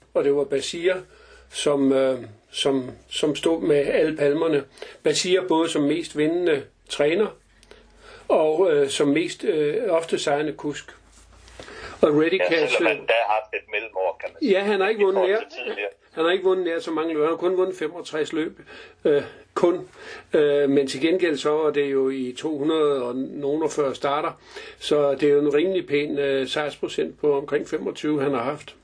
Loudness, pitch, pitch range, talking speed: -23 LUFS, 155 Hz, 145-190 Hz, 160 wpm